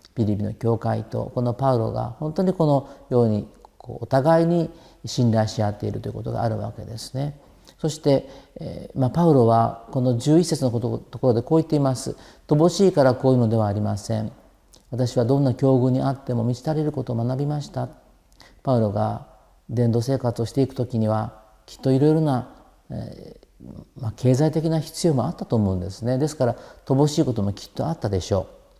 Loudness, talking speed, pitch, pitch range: -22 LUFS, 390 characters per minute, 125 Hz, 115-145 Hz